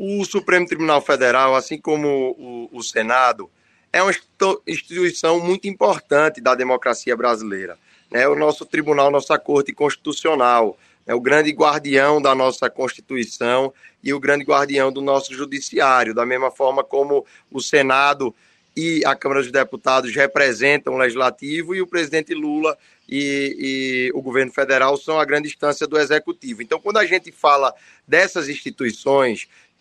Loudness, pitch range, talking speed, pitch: -18 LUFS, 130-155 Hz, 150 wpm, 140 Hz